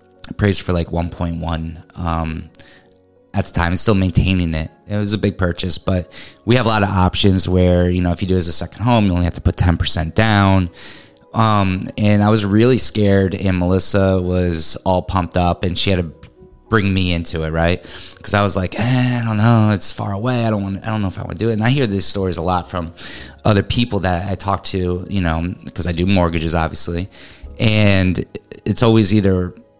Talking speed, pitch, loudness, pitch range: 230 wpm, 95 Hz, -17 LUFS, 85-105 Hz